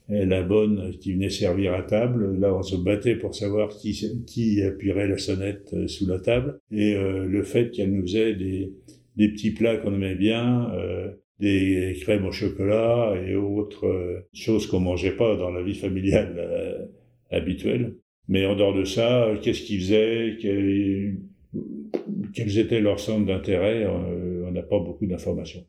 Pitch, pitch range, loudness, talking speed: 100 Hz, 95-110 Hz, -25 LUFS, 170 wpm